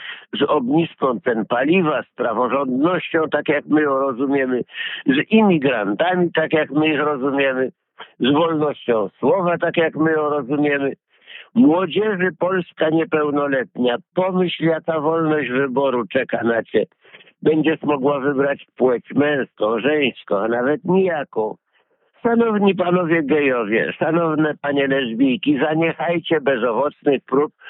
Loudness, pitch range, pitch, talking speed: -19 LUFS, 140-175 Hz, 155 Hz, 120 wpm